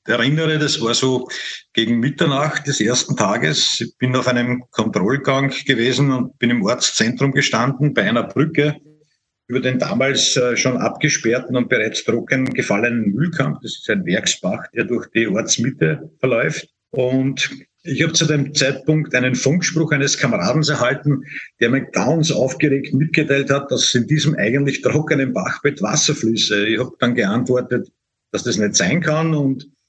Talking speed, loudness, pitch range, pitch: 155 wpm, -18 LUFS, 125-150 Hz, 135 Hz